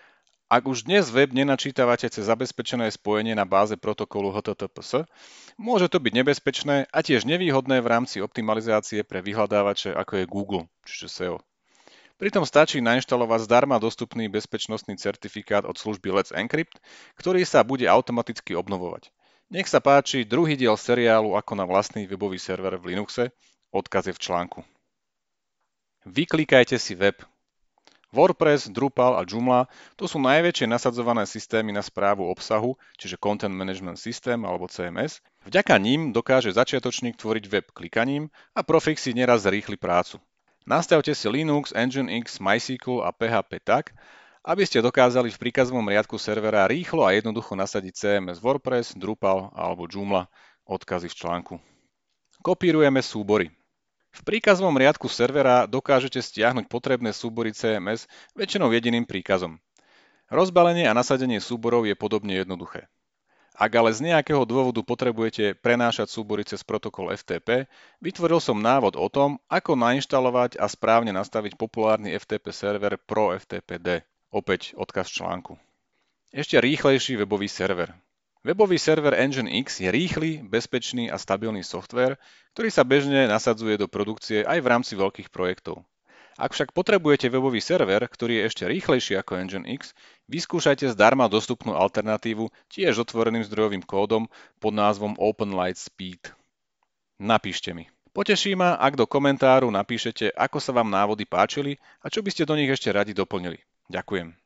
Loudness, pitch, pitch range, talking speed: -24 LUFS, 115 Hz, 100-130 Hz, 140 wpm